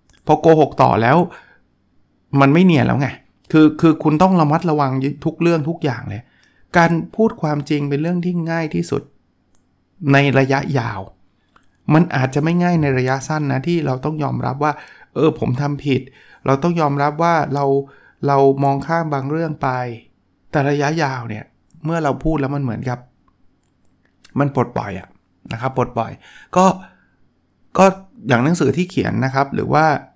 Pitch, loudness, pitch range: 140 Hz, -17 LUFS, 130-160 Hz